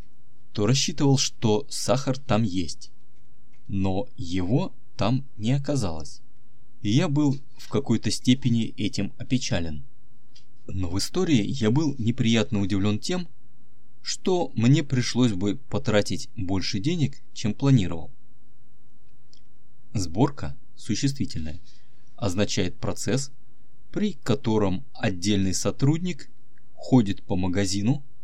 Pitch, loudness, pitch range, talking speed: 120 Hz, -26 LUFS, 105-130 Hz, 100 wpm